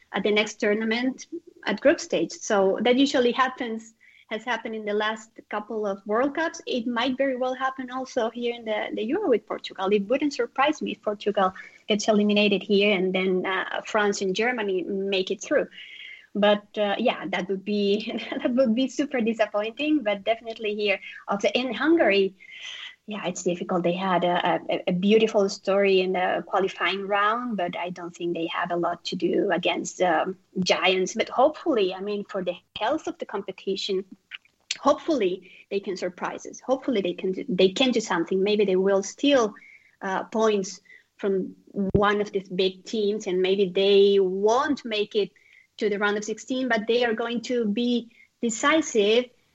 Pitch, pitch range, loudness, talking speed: 210 Hz, 195-245 Hz, -25 LUFS, 180 wpm